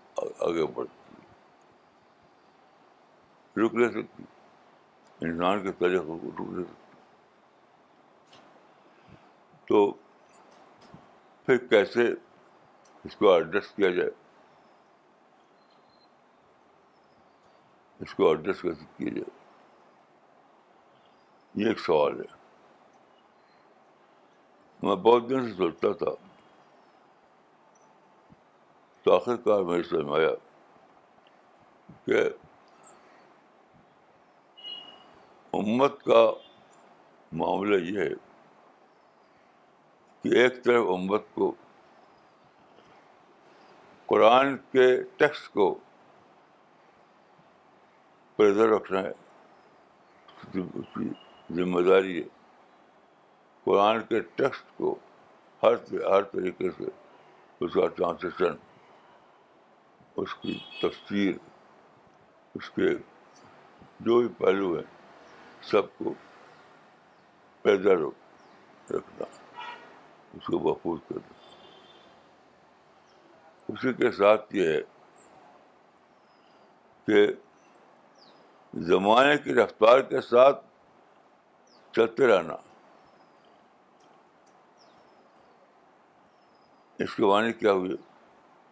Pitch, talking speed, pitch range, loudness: 390 Hz, 75 wpm, 345-440 Hz, -26 LUFS